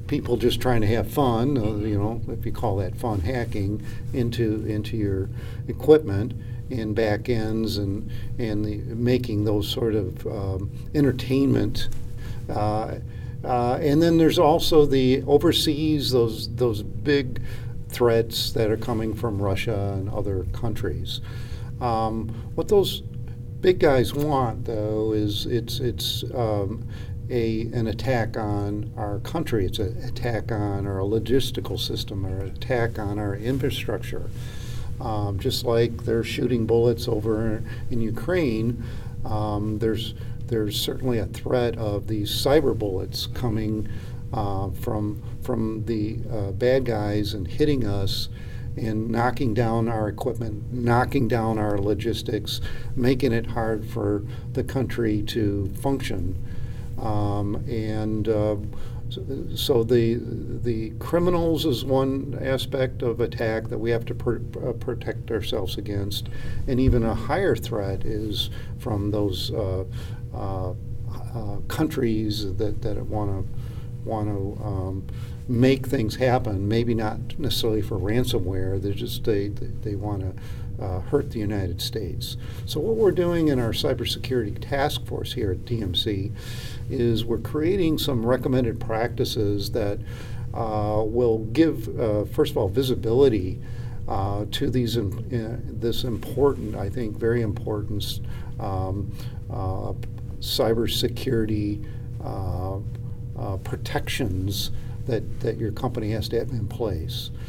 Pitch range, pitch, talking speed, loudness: 105-120 Hz, 115 Hz, 135 wpm, -25 LUFS